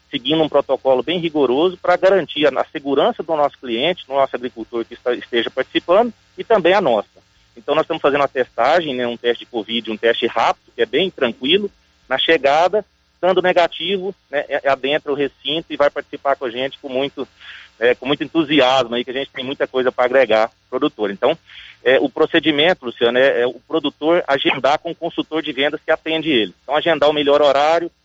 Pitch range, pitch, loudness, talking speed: 130-165 Hz, 145 Hz, -18 LUFS, 210 wpm